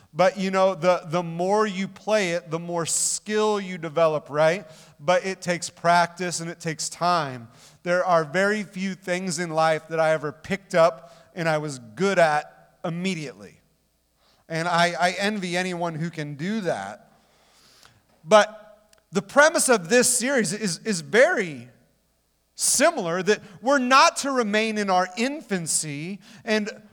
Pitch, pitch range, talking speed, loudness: 180 Hz, 165-210 Hz, 155 wpm, -23 LUFS